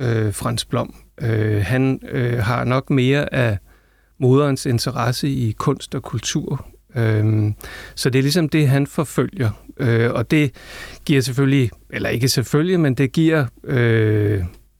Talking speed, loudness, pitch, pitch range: 145 wpm, -19 LUFS, 130 Hz, 110-140 Hz